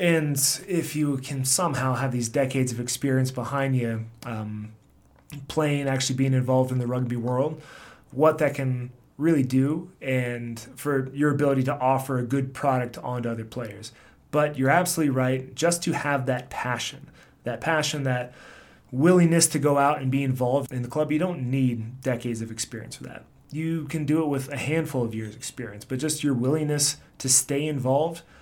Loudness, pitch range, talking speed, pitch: -25 LUFS, 125-150 Hz, 180 wpm, 135 Hz